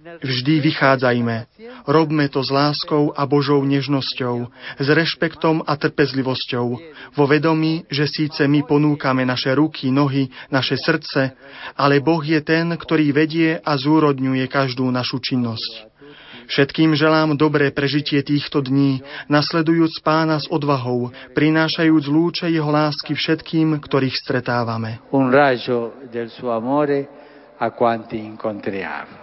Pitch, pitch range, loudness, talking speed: 145 Hz, 130-155 Hz, -19 LUFS, 105 wpm